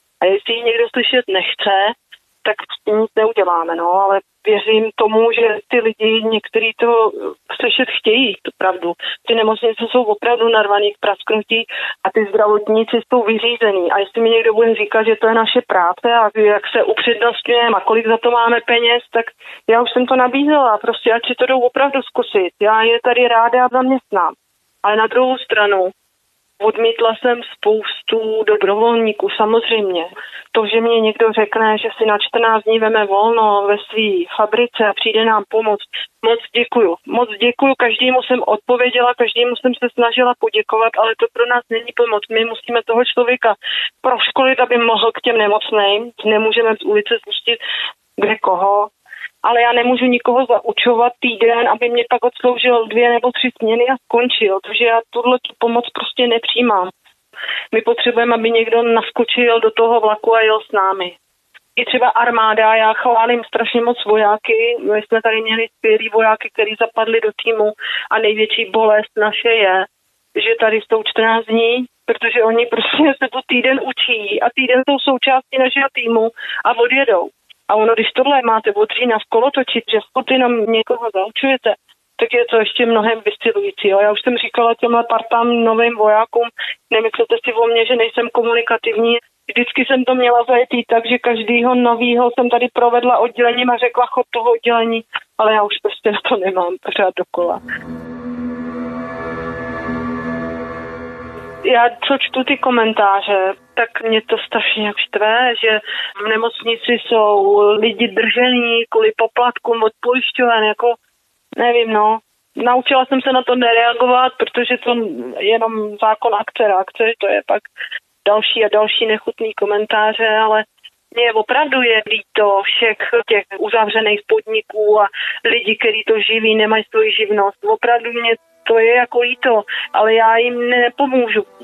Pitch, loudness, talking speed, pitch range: 230 Hz, -15 LUFS, 160 wpm, 215-245 Hz